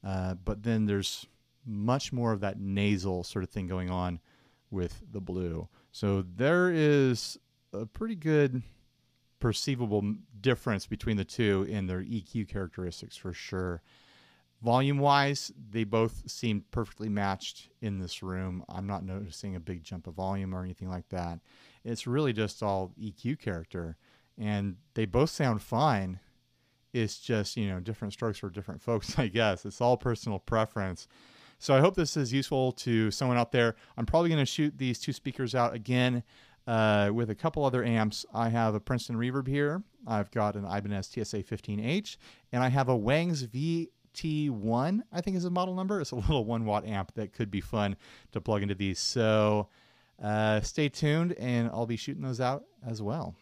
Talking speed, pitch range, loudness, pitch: 175 wpm, 100-130 Hz, -31 LUFS, 110 Hz